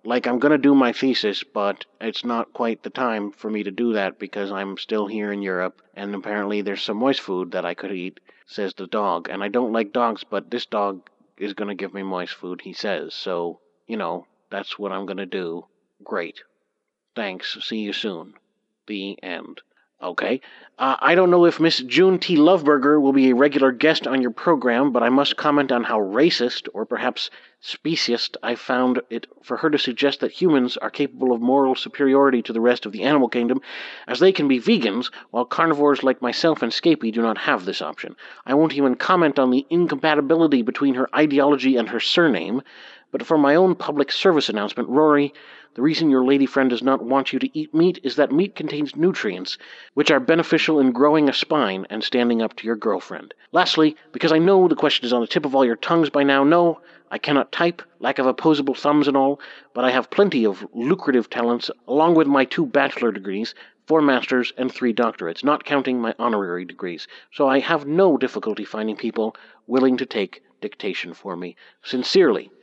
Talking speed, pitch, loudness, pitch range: 205 wpm, 130 Hz, -20 LUFS, 115-150 Hz